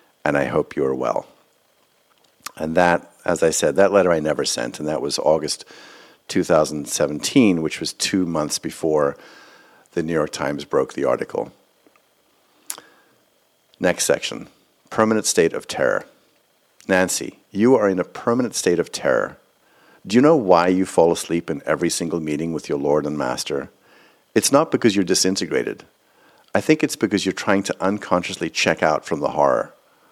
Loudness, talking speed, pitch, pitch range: -20 LUFS, 165 wpm, 95 Hz, 85-105 Hz